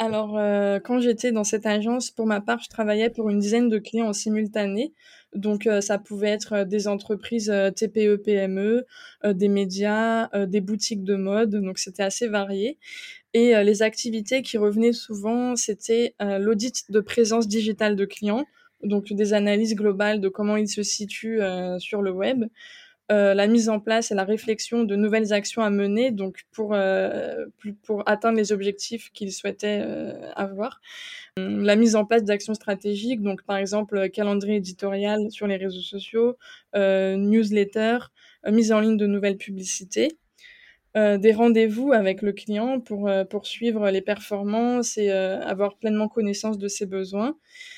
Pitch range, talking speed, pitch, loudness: 200-230 Hz, 170 wpm, 210 Hz, -24 LUFS